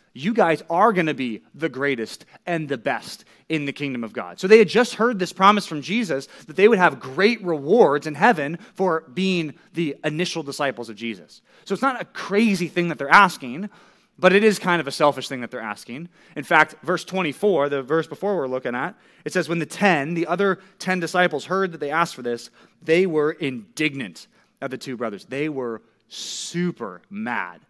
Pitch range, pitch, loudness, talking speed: 140-190 Hz, 165 Hz, -21 LUFS, 210 wpm